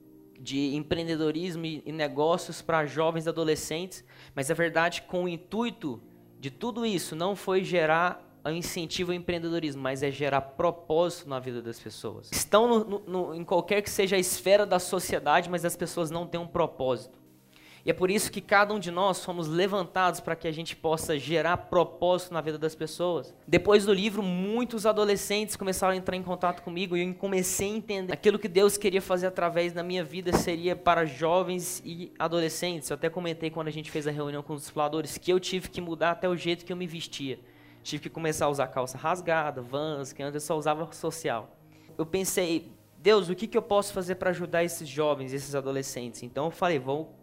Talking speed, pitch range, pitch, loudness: 200 wpm, 155-185 Hz, 170 Hz, -29 LUFS